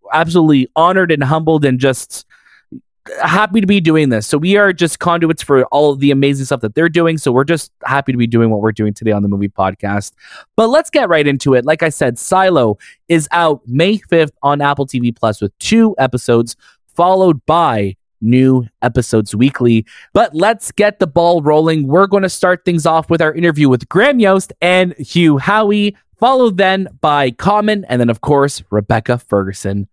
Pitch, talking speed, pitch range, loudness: 150 Hz, 195 wpm, 125-180 Hz, -13 LUFS